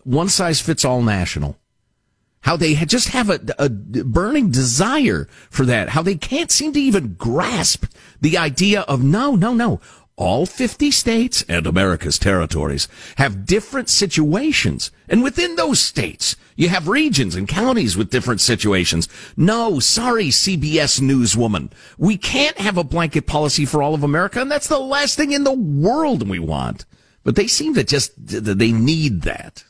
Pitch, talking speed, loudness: 155 Hz, 165 wpm, -17 LUFS